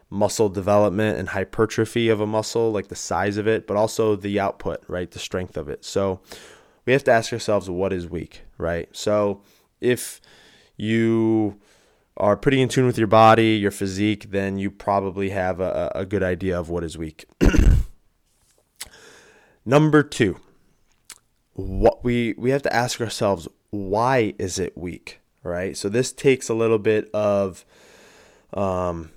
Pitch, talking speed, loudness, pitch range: 105 Hz, 160 wpm, -22 LUFS, 95-115 Hz